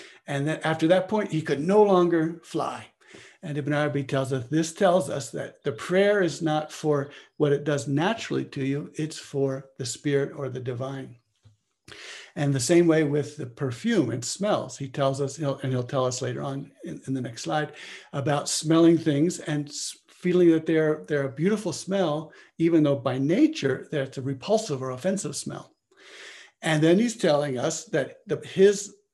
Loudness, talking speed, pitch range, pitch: -25 LUFS, 185 wpm, 140-170 Hz, 150 Hz